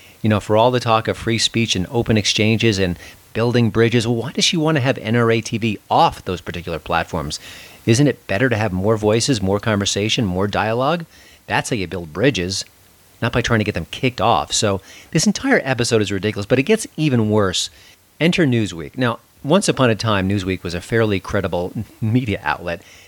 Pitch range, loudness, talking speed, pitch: 95-120 Hz, -18 LUFS, 200 wpm, 110 Hz